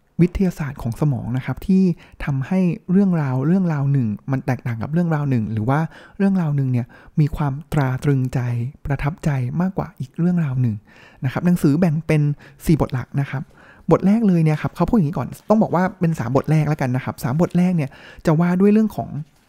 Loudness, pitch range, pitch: -20 LUFS, 135-175 Hz, 150 Hz